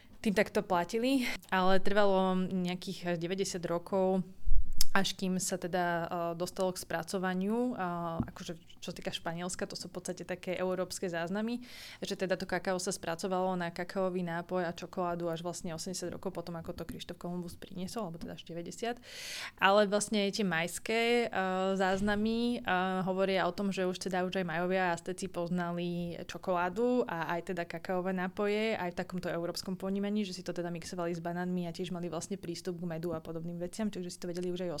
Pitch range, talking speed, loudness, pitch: 175-195 Hz, 180 wpm, -34 LUFS, 185 Hz